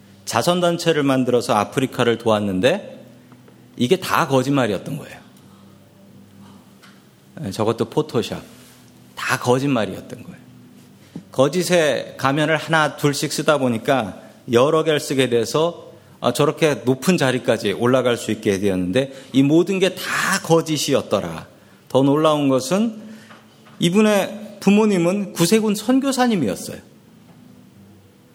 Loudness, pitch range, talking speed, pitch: -19 LUFS, 120-175 Hz, 260 characters per minute, 140 Hz